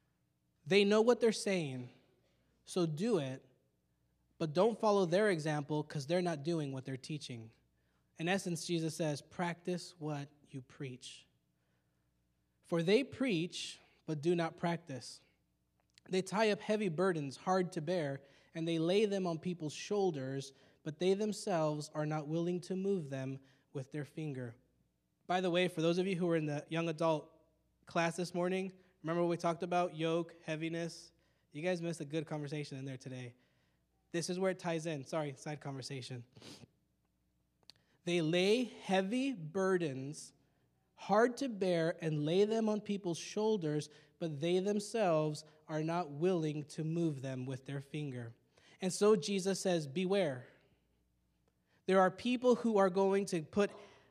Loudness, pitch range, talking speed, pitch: -36 LUFS, 135-185 Hz, 155 wpm, 165 Hz